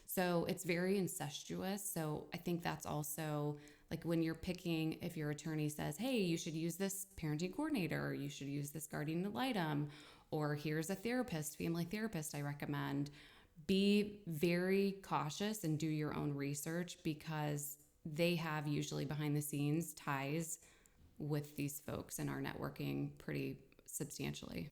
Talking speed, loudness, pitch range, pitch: 155 wpm, -41 LUFS, 145-175 Hz, 155 Hz